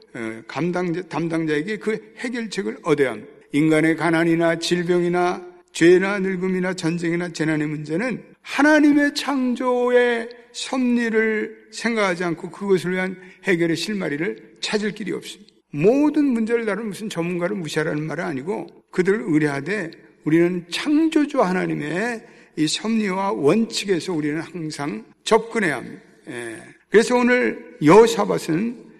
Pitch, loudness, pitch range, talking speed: 185 Hz, -21 LUFS, 165-225 Hz, 315 characters per minute